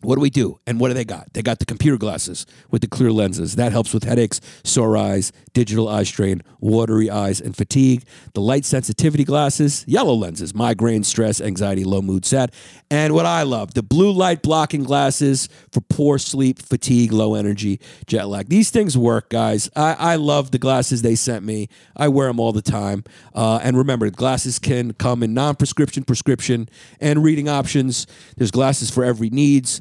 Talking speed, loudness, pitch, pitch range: 190 wpm, -19 LUFS, 125 Hz, 110-140 Hz